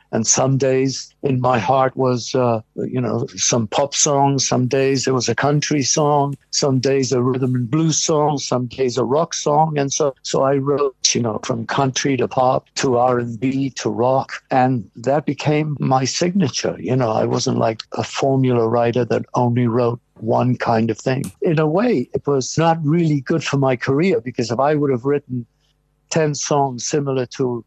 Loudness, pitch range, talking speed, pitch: -18 LUFS, 125-145 Hz, 190 wpm, 135 Hz